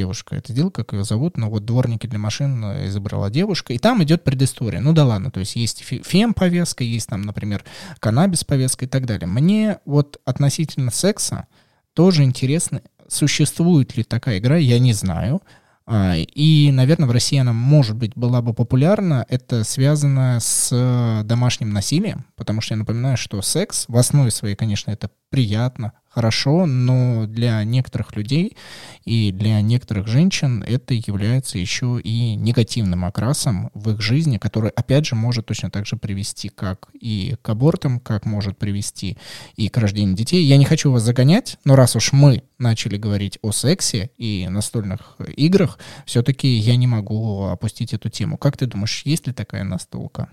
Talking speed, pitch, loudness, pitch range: 165 wpm, 120 Hz, -19 LUFS, 110-140 Hz